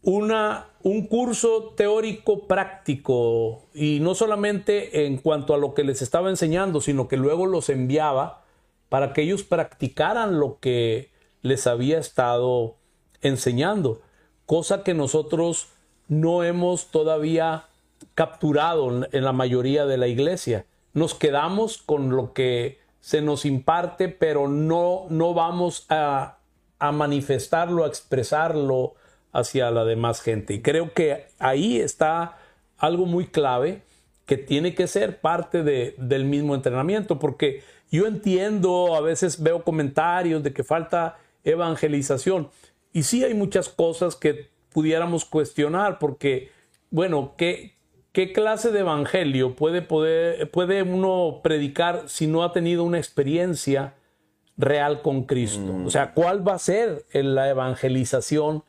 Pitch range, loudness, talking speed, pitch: 140-180 Hz, -23 LUFS, 135 wpm, 155 Hz